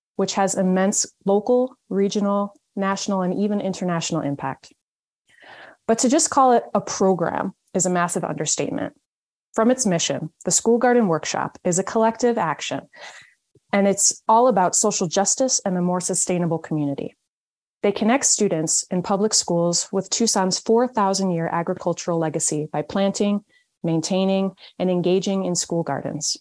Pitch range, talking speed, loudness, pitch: 175-210 Hz, 145 wpm, -21 LUFS, 195 Hz